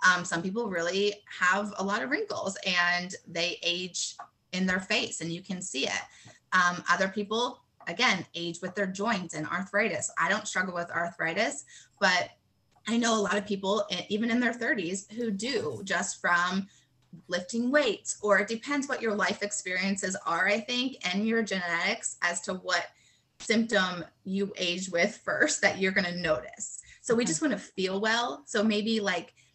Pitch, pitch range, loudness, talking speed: 195 Hz, 175-215 Hz, -29 LUFS, 180 wpm